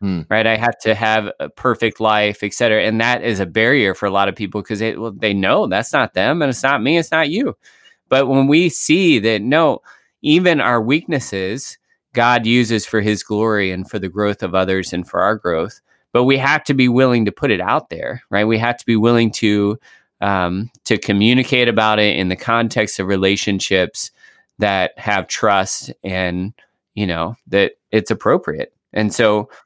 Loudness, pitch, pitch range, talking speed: -16 LUFS, 110 Hz, 100-125 Hz, 195 wpm